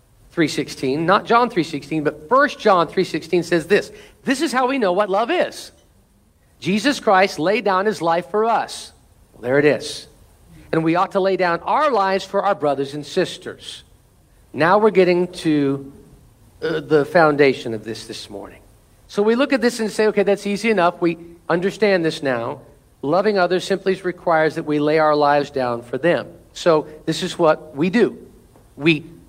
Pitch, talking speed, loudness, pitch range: 170 Hz, 180 wpm, -19 LUFS, 145-195 Hz